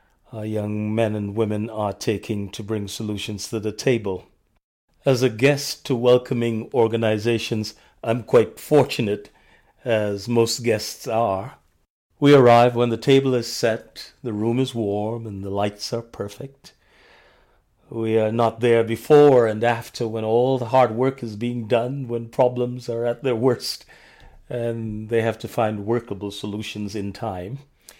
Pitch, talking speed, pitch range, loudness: 115 Hz, 155 wpm, 105-120 Hz, -21 LUFS